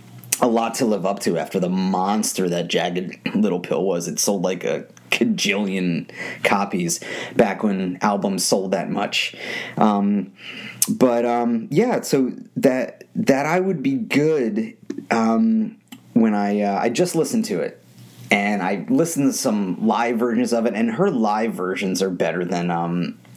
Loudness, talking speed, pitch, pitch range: -21 LUFS, 160 wpm, 105 Hz, 95-135 Hz